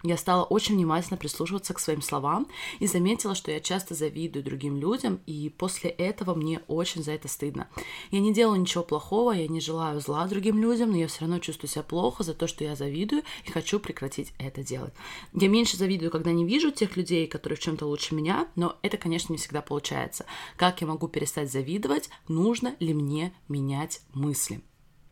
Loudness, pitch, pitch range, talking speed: -28 LUFS, 165 Hz, 150-190 Hz, 195 wpm